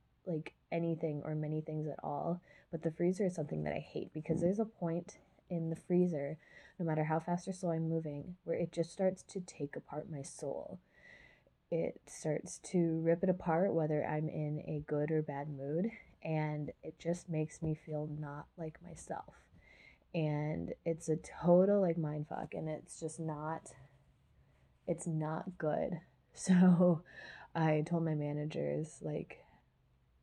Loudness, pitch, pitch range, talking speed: -37 LUFS, 160 Hz, 150-175 Hz, 165 wpm